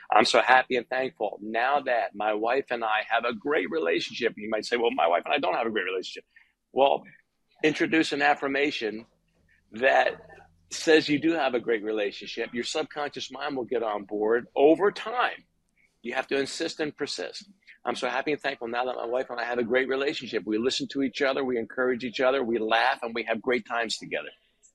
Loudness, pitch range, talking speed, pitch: -26 LUFS, 115-145 Hz, 210 wpm, 130 Hz